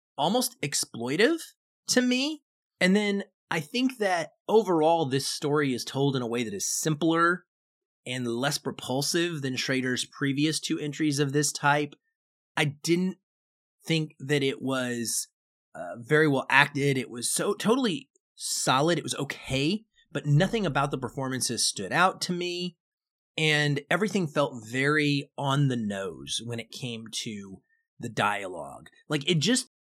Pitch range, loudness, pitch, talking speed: 135-185 Hz, -27 LUFS, 150 Hz, 150 wpm